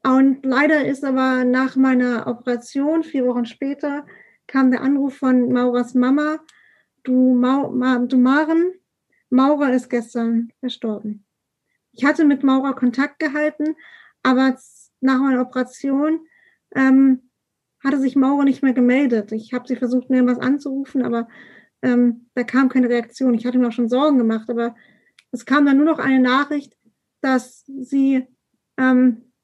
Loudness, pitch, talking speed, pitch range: -19 LUFS, 260 Hz, 150 wpm, 245-275 Hz